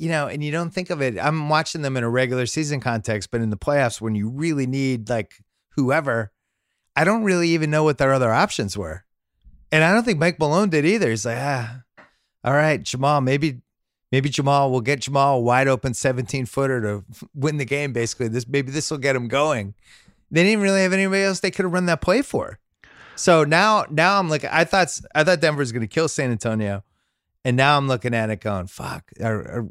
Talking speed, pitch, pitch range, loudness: 225 wpm, 135 Hz, 115-155 Hz, -21 LUFS